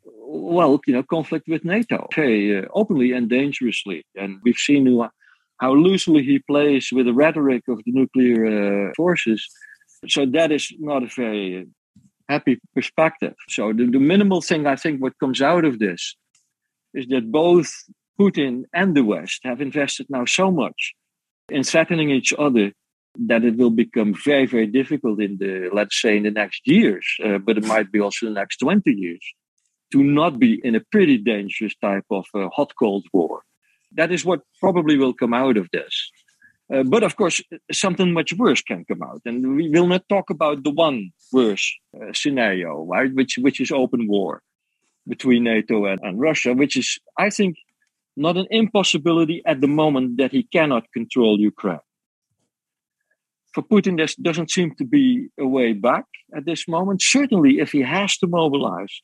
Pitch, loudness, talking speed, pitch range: 140 Hz, -19 LUFS, 180 wpm, 120-175 Hz